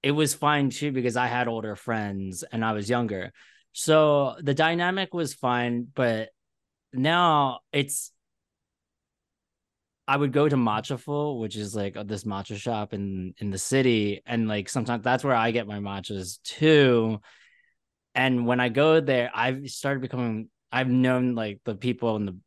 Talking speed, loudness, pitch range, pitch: 165 wpm, -25 LUFS, 105-135 Hz, 120 Hz